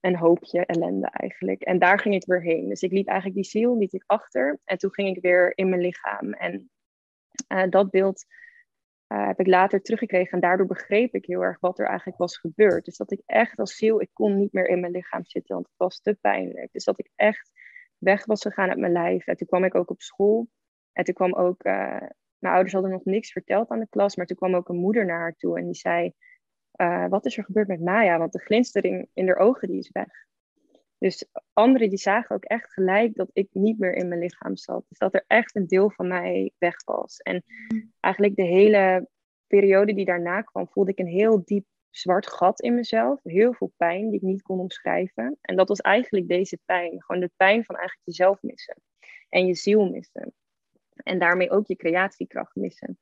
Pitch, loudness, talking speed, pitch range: 190 Hz, -23 LUFS, 225 wpm, 180-210 Hz